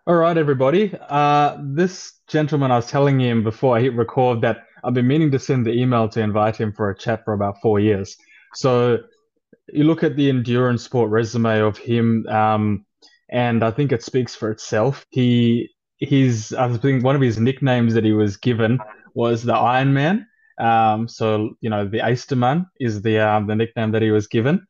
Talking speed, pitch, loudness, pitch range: 195 wpm, 120 Hz, -19 LUFS, 110-140 Hz